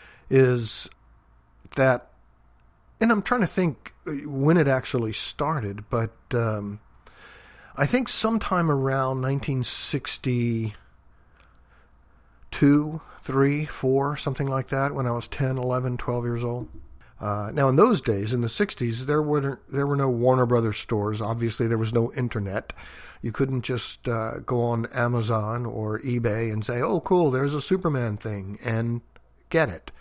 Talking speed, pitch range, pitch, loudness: 145 wpm, 110-140 Hz, 120 Hz, -25 LUFS